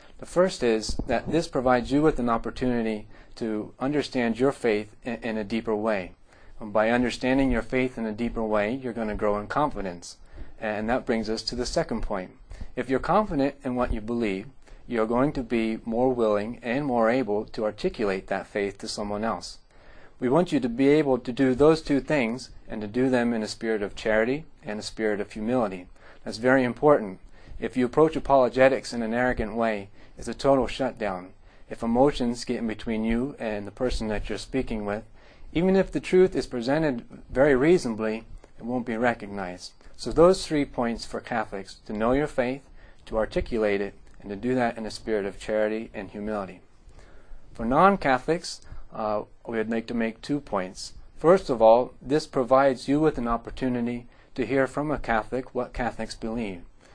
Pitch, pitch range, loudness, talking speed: 115 Hz, 110-130 Hz, -26 LUFS, 190 wpm